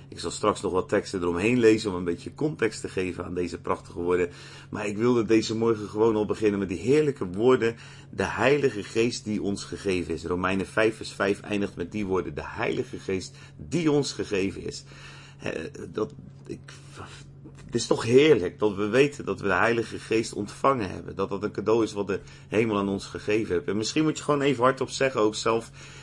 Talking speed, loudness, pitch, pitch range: 210 wpm, -26 LUFS, 110 Hz, 100-130 Hz